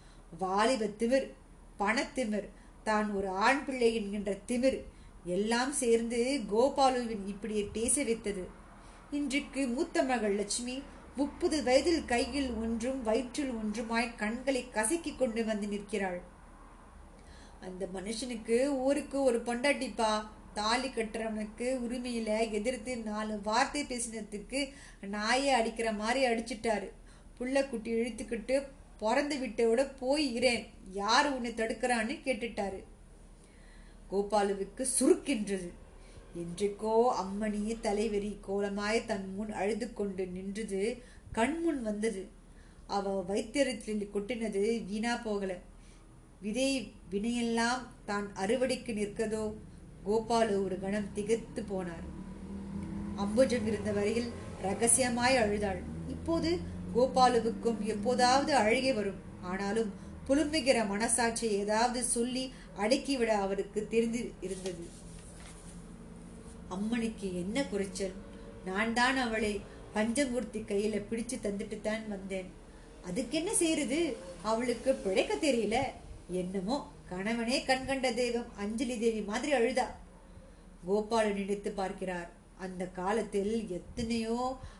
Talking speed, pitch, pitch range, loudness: 95 wpm, 225 Hz, 200-250 Hz, -32 LUFS